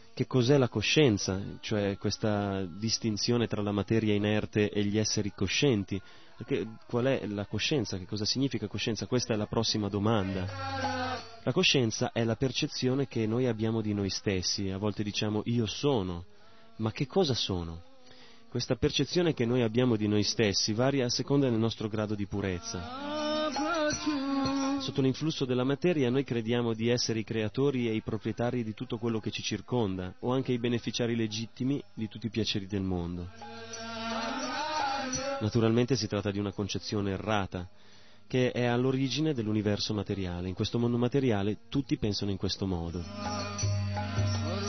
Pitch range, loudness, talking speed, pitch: 105-130 Hz, -30 LUFS, 155 wpm, 115 Hz